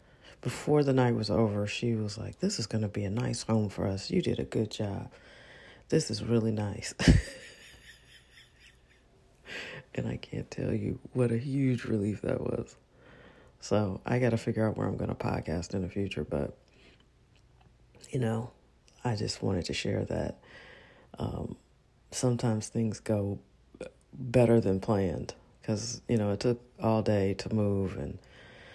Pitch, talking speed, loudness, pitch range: 110 Hz, 165 wpm, -31 LUFS, 100-120 Hz